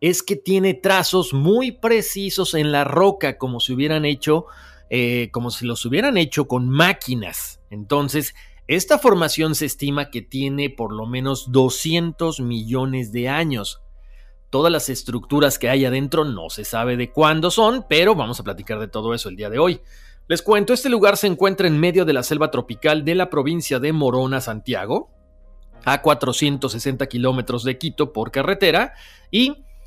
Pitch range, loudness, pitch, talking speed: 120-165 Hz, -19 LUFS, 140 Hz, 170 wpm